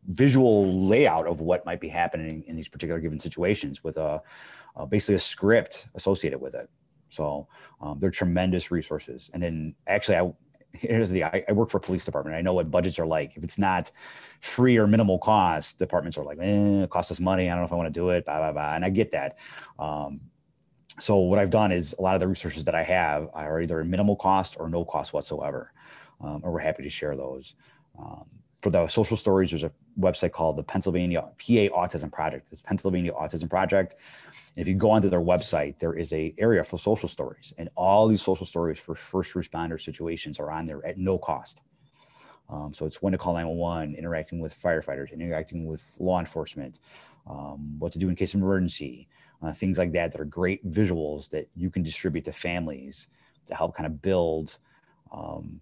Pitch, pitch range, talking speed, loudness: 85 Hz, 80-95 Hz, 210 wpm, -26 LUFS